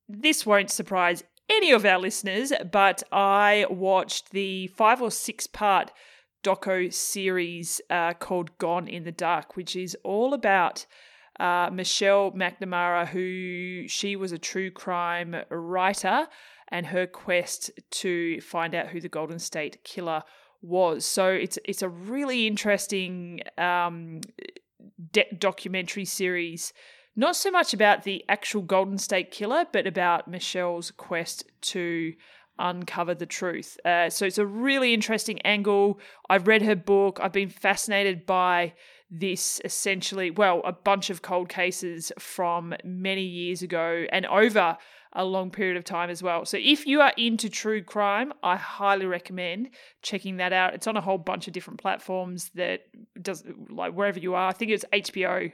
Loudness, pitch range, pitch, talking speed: -26 LUFS, 175-205 Hz, 190 Hz, 155 wpm